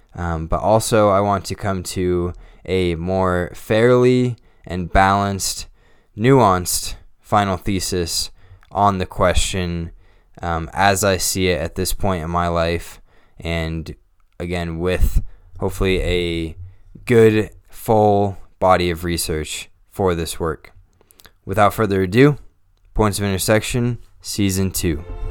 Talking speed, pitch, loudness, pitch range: 120 wpm, 95 Hz, -19 LUFS, 85-100 Hz